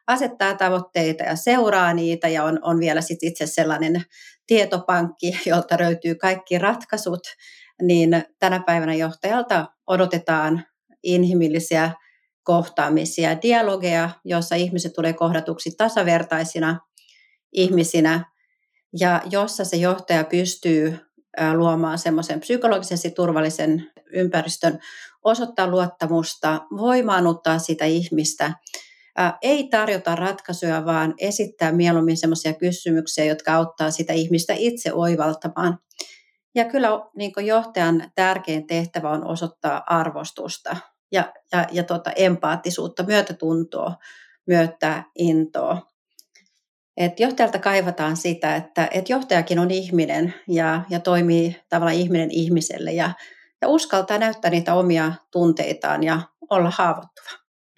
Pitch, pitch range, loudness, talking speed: 175 Hz, 165-195 Hz, -21 LUFS, 105 wpm